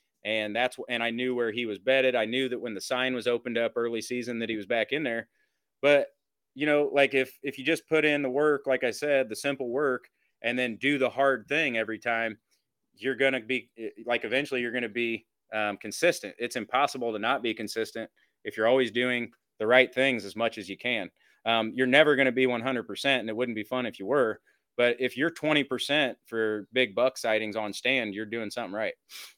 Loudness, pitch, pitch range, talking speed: -27 LUFS, 125 Hz, 115-135 Hz, 225 wpm